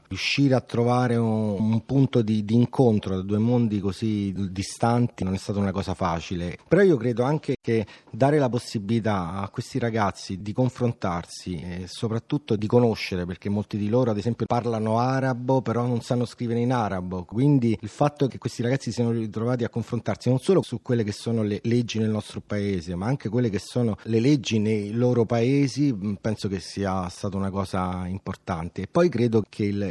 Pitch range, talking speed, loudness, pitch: 100-120 Hz, 190 wpm, -25 LUFS, 115 Hz